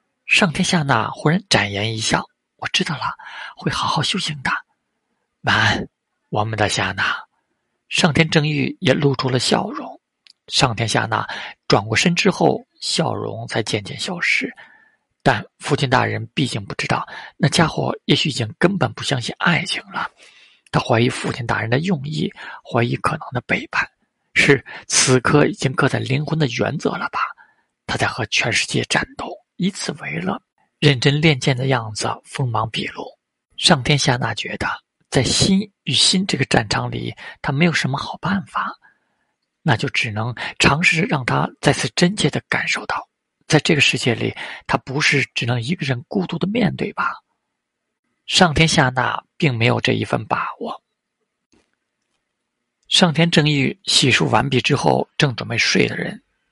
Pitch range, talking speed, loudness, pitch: 125-175 Hz, 230 characters per minute, -19 LUFS, 145 Hz